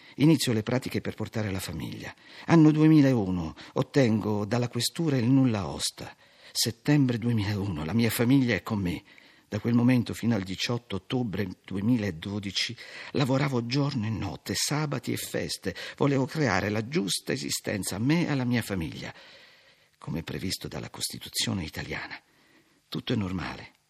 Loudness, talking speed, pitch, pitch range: -27 LUFS, 145 wpm, 120 Hz, 100-130 Hz